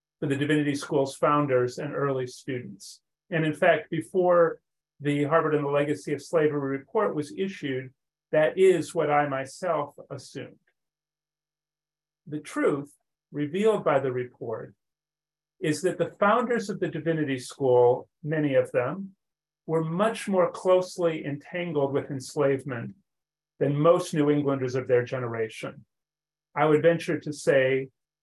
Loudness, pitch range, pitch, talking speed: -26 LUFS, 140-165 Hz, 150 Hz, 135 wpm